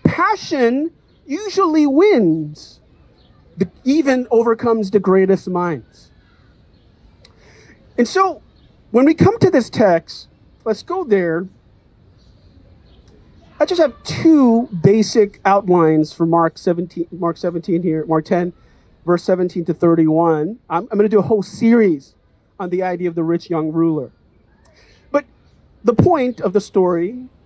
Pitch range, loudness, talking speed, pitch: 165-235 Hz, -16 LUFS, 130 wpm, 185 Hz